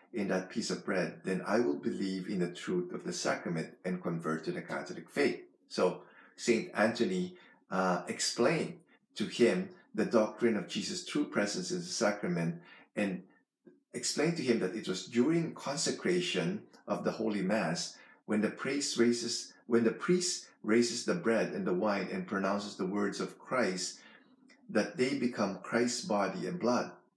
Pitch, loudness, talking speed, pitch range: 105 Hz, -33 LUFS, 170 wpm, 90-120 Hz